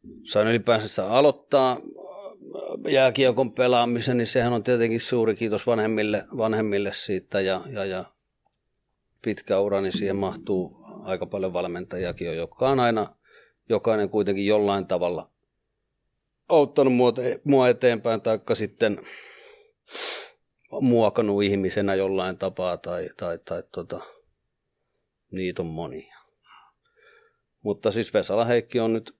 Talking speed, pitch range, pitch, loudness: 110 wpm, 100-130 Hz, 115 Hz, -24 LUFS